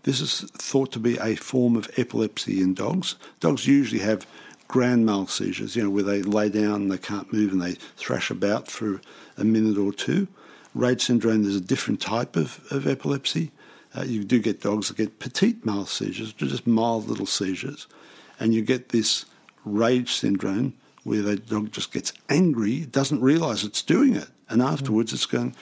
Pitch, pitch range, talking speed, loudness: 110 Hz, 105-125 Hz, 185 wpm, -24 LUFS